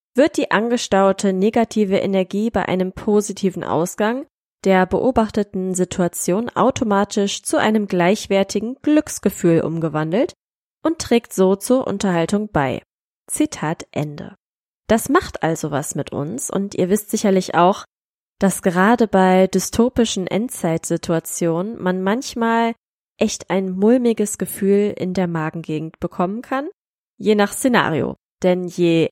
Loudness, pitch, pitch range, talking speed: -19 LUFS, 195 Hz, 180-230 Hz, 120 wpm